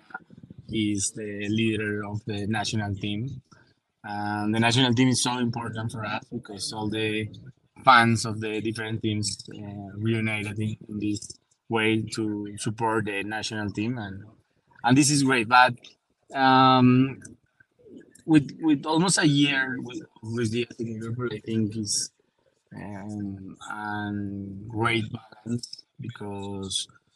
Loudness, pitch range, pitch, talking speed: -25 LUFS, 105-125 Hz, 110 Hz, 130 wpm